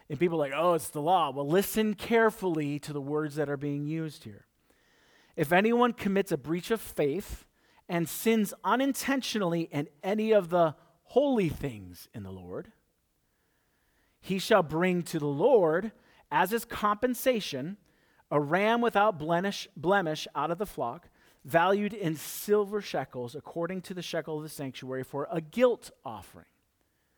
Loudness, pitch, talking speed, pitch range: -29 LUFS, 170 Hz, 155 wpm, 150-210 Hz